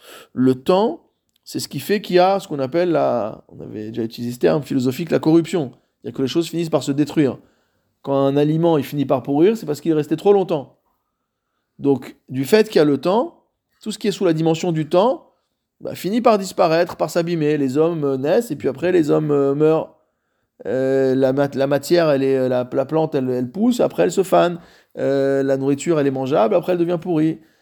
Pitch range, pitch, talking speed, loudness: 135-175 Hz, 150 Hz, 230 wpm, -19 LUFS